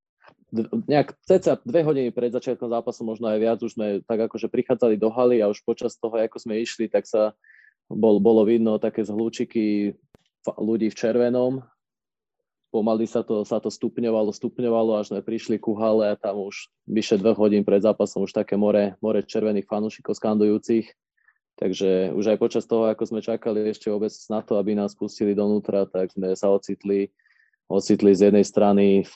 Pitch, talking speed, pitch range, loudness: 110 Hz, 180 wpm, 105-115 Hz, -23 LUFS